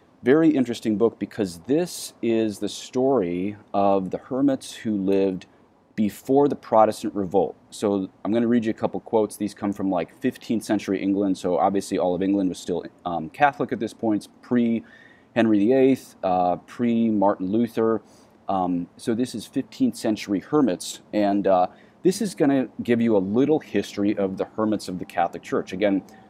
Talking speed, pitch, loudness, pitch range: 180 wpm, 105 Hz, -23 LUFS, 100-120 Hz